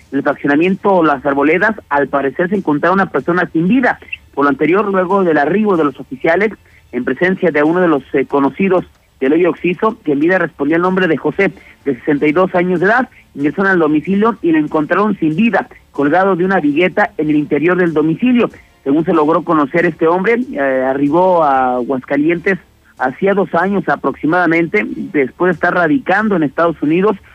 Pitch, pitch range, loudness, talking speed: 170 Hz, 150-190 Hz, -14 LUFS, 180 wpm